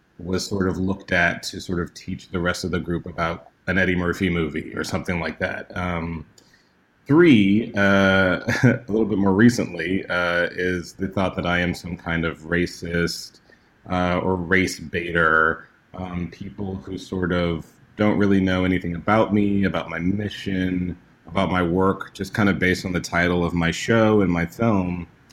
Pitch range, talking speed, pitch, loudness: 85-95 Hz, 180 wpm, 90 Hz, -22 LUFS